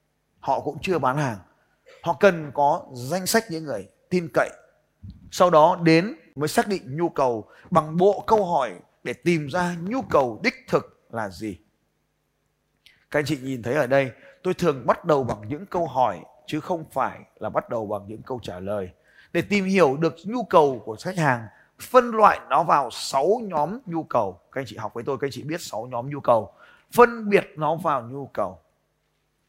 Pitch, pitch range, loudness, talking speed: 155 Hz, 130-180 Hz, -23 LUFS, 200 wpm